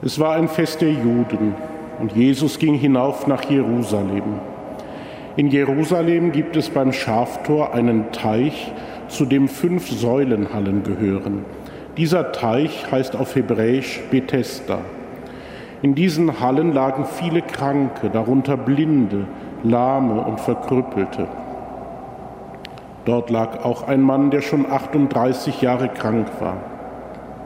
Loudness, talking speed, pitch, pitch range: -19 LUFS, 115 wpm, 135 Hz, 115-145 Hz